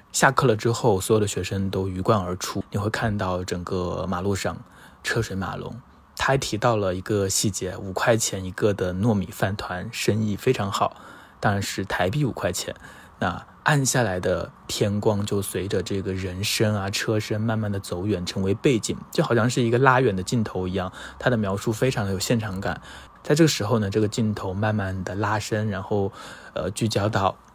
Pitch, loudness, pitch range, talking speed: 105 Hz, -24 LUFS, 95-115 Hz, 285 characters per minute